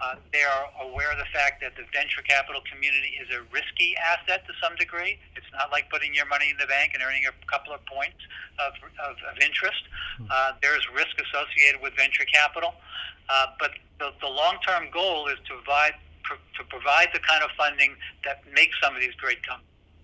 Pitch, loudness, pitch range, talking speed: 145 Hz, -24 LUFS, 135-150 Hz, 205 wpm